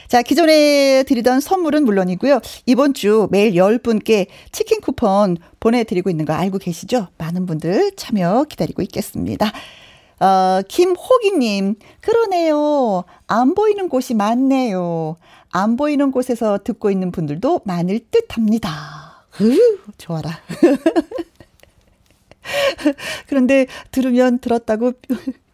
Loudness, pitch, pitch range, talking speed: -17 LUFS, 240 Hz, 195-280 Hz, 250 characters per minute